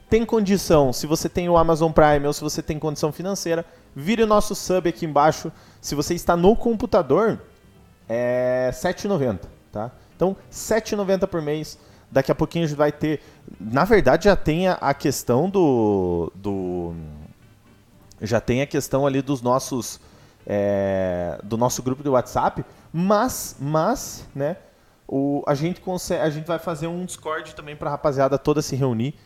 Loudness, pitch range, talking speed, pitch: -22 LUFS, 120-170 Hz, 165 wpm, 150 Hz